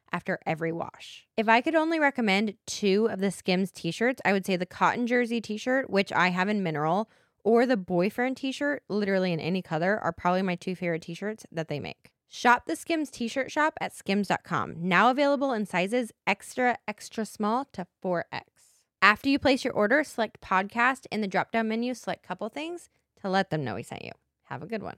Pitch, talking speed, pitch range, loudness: 210 Hz, 215 wpm, 180-250 Hz, -27 LUFS